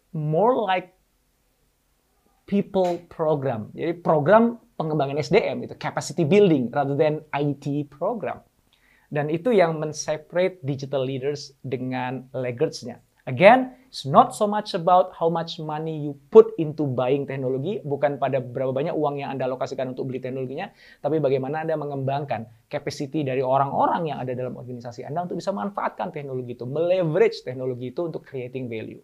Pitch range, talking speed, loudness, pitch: 130-165 Hz, 150 wpm, -24 LUFS, 145 Hz